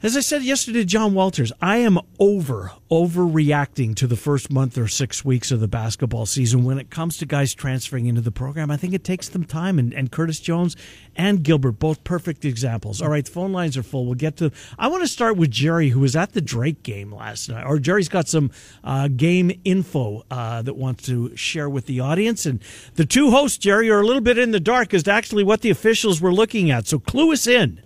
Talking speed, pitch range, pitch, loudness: 235 wpm, 130-190 Hz, 155 Hz, -20 LUFS